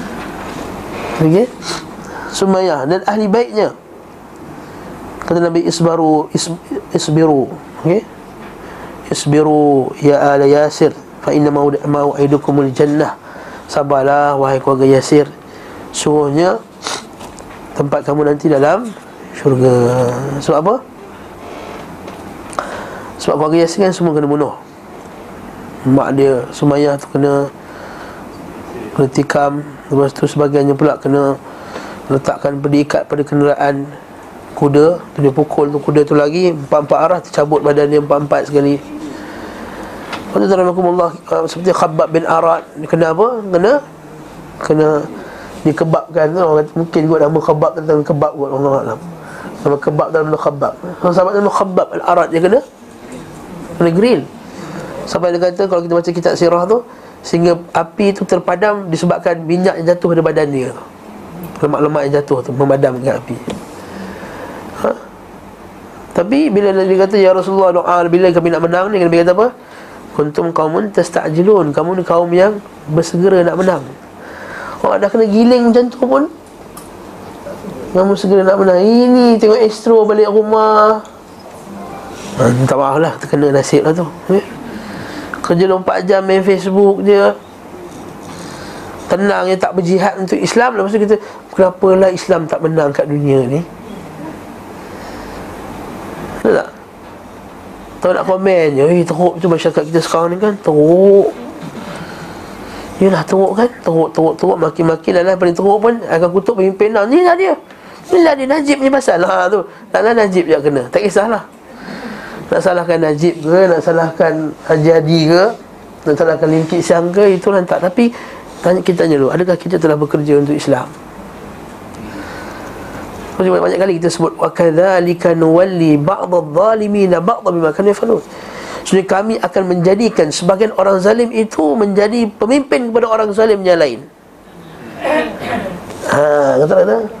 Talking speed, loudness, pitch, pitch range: 140 wpm, -13 LUFS, 170 Hz, 150-195 Hz